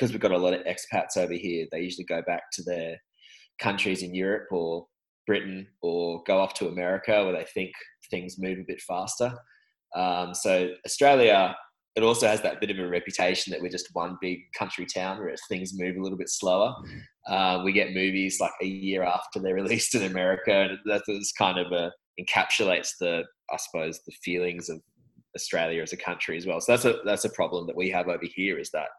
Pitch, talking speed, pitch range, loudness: 95 Hz, 210 wpm, 90-95 Hz, -27 LUFS